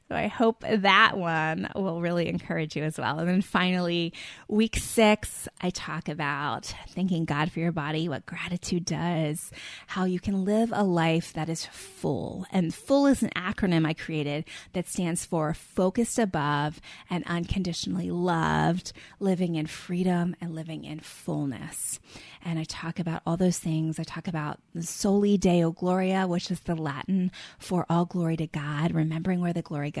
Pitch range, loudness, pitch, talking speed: 160-185 Hz, -28 LUFS, 170 Hz, 170 wpm